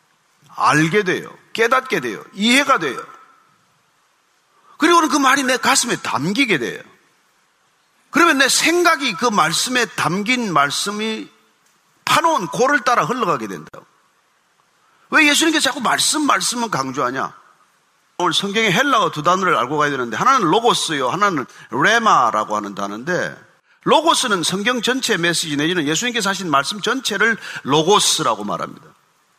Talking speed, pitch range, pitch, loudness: 305 characters per minute, 180-285 Hz, 240 Hz, -17 LUFS